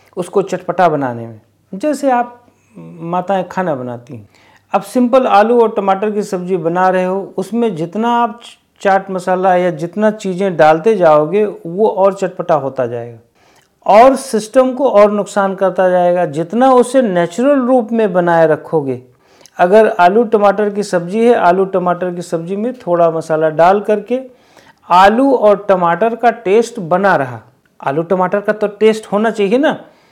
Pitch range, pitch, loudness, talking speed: 175-225 Hz, 195 Hz, -13 LUFS, 155 wpm